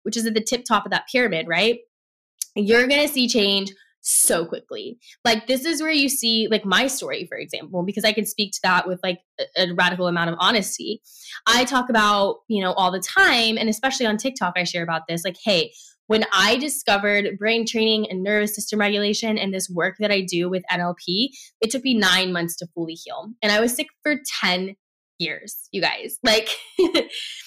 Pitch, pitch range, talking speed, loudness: 215 Hz, 185-245 Hz, 210 wpm, -21 LUFS